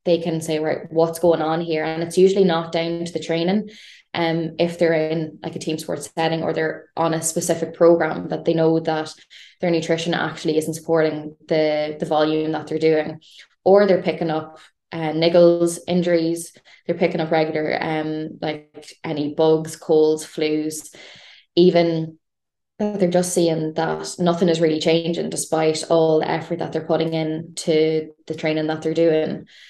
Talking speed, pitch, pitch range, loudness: 175 wpm, 160 Hz, 155-170 Hz, -20 LUFS